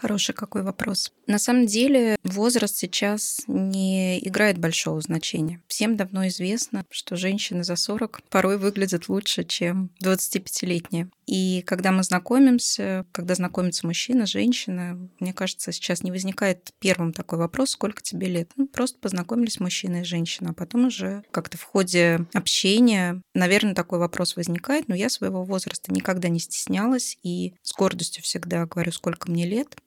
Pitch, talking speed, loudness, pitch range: 190 Hz, 150 wpm, -24 LUFS, 175-210 Hz